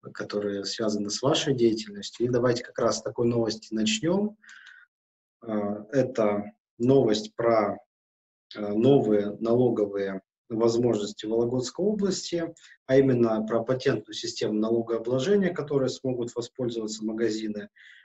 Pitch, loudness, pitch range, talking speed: 115 Hz, -26 LUFS, 105-130 Hz, 105 wpm